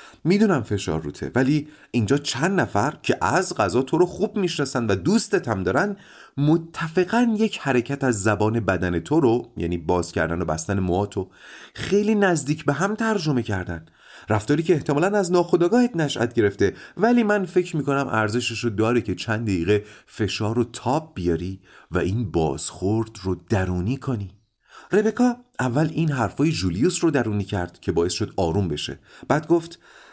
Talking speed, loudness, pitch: 160 wpm, -22 LUFS, 125 Hz